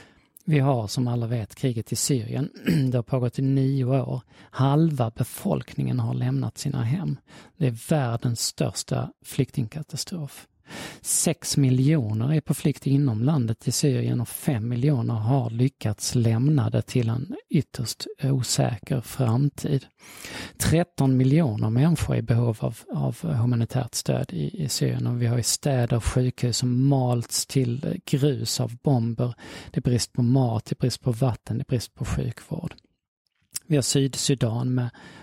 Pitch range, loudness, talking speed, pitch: 120-140 Hz, -25 LUFS, 150 wpm, 130 Hz